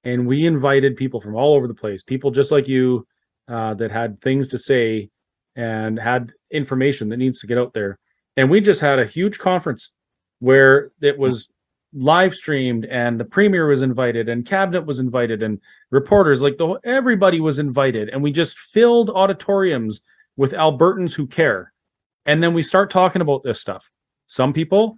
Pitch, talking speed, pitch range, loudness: 135 Hz, 180 wpm, 120-165 Hz, -18 LUFS